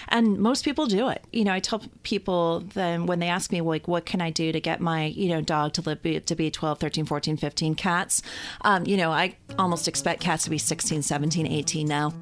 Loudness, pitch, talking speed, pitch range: -25 LUFS, 165 Hz, 235 wpm, 155-185 Hz